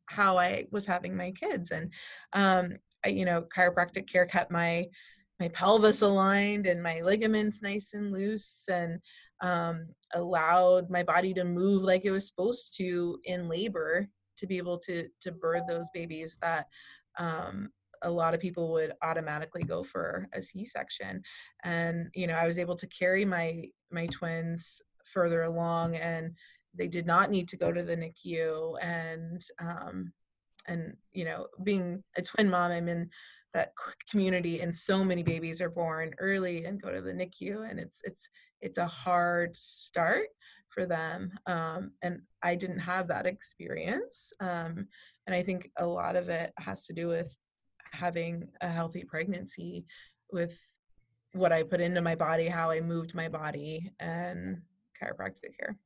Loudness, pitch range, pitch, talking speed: -32 LUFS, 165-185 Hz, 175 Hz, 165 wpm